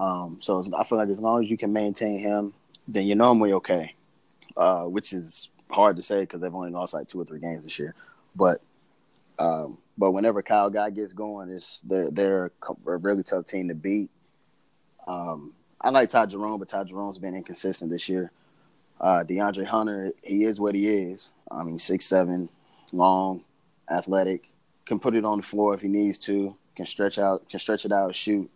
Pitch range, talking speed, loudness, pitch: 95-105 Hz, 200 wpm, -26 LUFS, 100 Hz